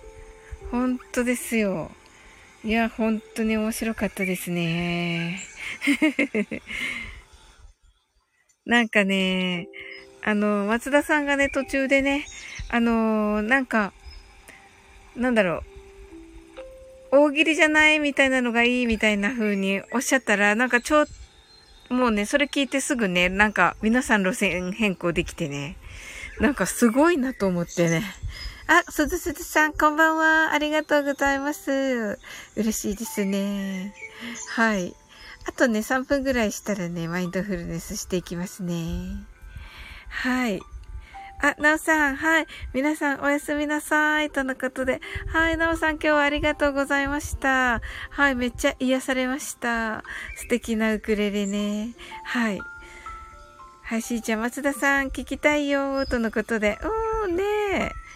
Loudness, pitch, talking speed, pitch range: -23 LUFS, 250 Hz, 270 characters per minute, 210-295 Hz